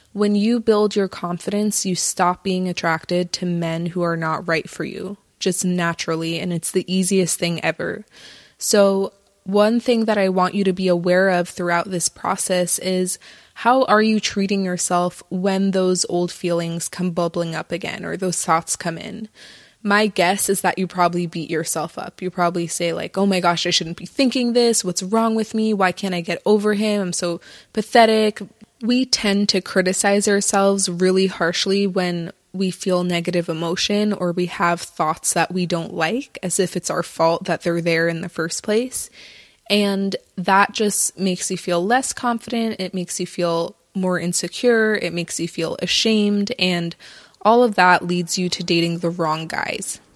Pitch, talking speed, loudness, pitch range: 185 Hz, 185 wpm, -20 LUFS, 175-205 Hz